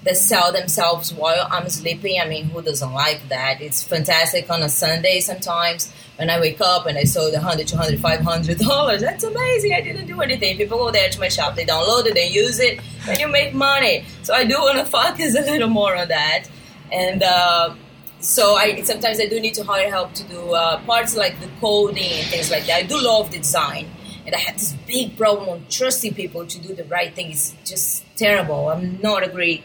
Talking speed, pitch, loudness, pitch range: 230 wpm, 180 Hz, -18 LUFS, 165-220 Hz